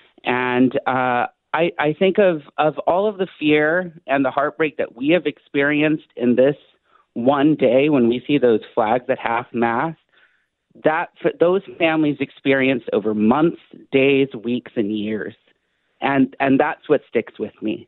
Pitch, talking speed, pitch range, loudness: 140 Hz, 160 wpm, 125-155 Hz, -19 LUFS